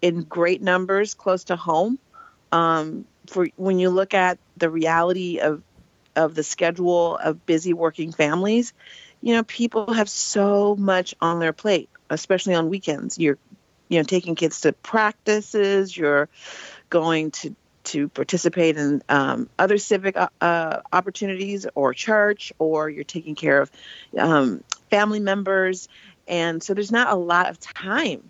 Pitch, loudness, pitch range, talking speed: 180 Hz, -22 LUFS, 165-200 Hz, 150 wpm